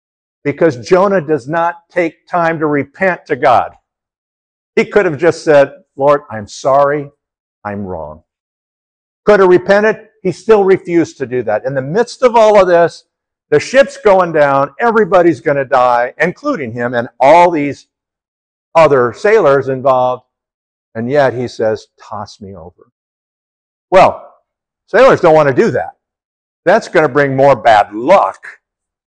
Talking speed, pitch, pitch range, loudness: 150 wpm, 150 Hz, 130-190 Hz, -11 LUFS